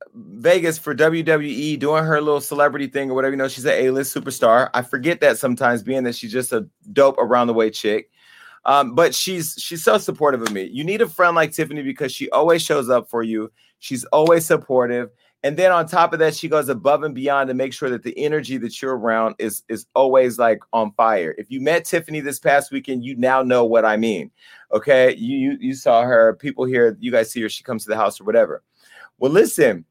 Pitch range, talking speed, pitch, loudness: 125-160 Hz, 230 wpm, 140 Hz, -19 LUFS